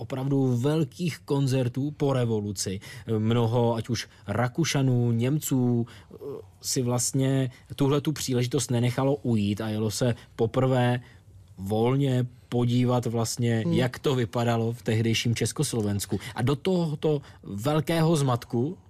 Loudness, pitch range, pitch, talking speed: -26 LUFS, 115-135 Hz, 120 Hz, 110 wpm